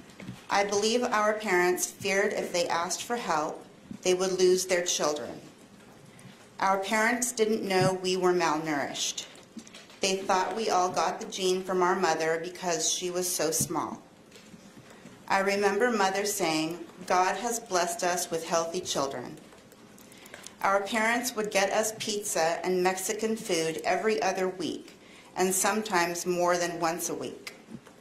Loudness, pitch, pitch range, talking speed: -28 LUFS, 185 Hz, 175-205 Hz, 145 wpm